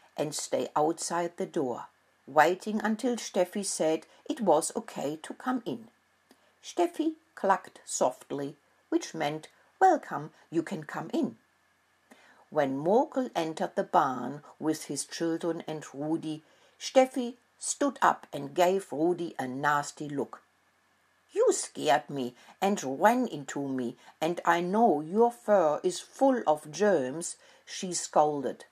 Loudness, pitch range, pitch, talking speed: -30 LUFS, 150-235 Hz, 175 Hz, 130 wpm